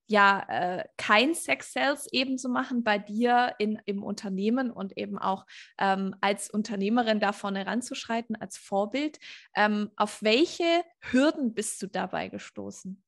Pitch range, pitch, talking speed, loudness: 200-245 Hz, 210 Hz, 145 wpm, -28 LUFS